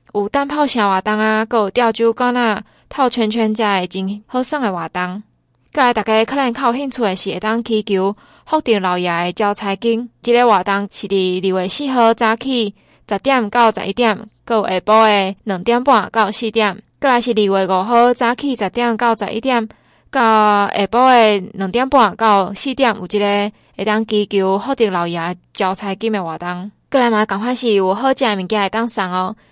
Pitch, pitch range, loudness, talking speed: 215 Hz, 195-240 Hz, -16 LUFS, 275 characters per minute